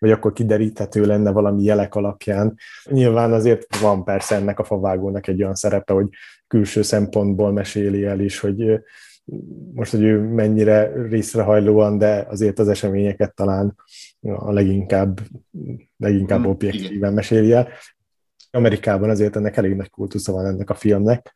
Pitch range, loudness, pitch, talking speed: 100-110 Hz, -19 LUFS, 105 Hz, 140 wpm